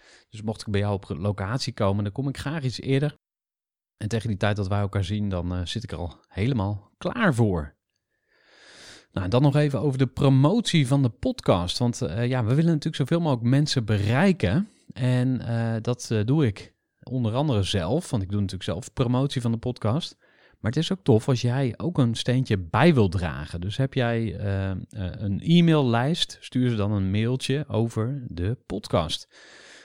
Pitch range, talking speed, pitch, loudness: 100-135 Hz, 195 wpm, 120 Hz, -25 LUFS